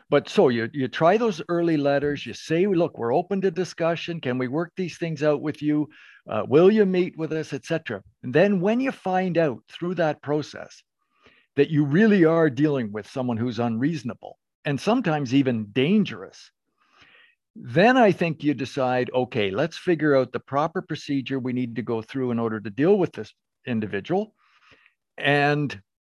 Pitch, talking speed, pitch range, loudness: 150 Hz, 180 wpm, 125-170 Hz, -23 LUFS